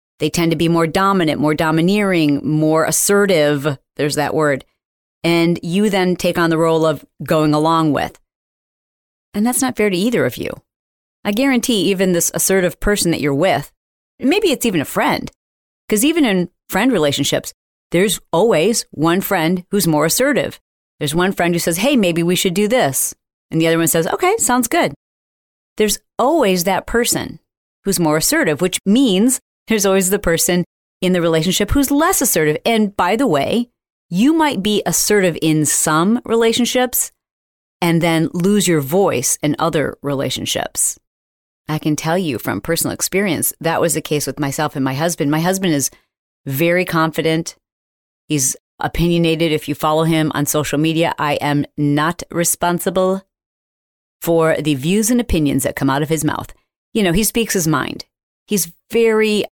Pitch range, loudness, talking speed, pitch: 155-200 Hz, -16 LUFS, 170 wpm, 170 Hz